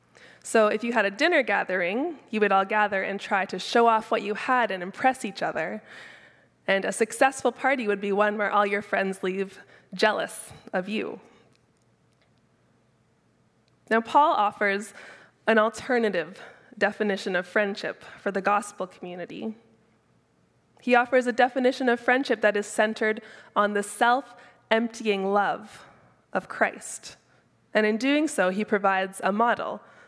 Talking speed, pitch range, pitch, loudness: 150 wpm, 200-240 Hz, 215 Hz, -25 LUFS